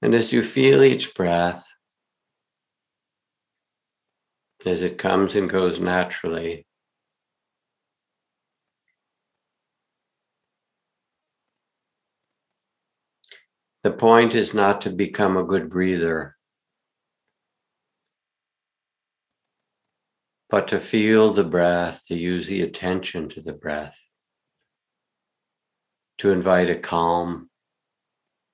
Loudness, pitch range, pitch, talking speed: -21 LUFS, 85-100 Hz, 90 Hz, 80 wpm